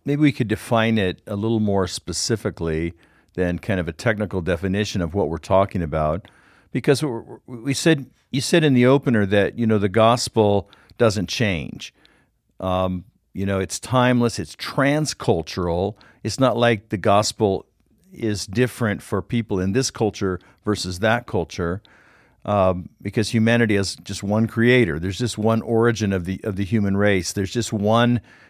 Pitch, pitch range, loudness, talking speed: 105 Hz, 95-120 Hz, -21 LUFS, 160 wpm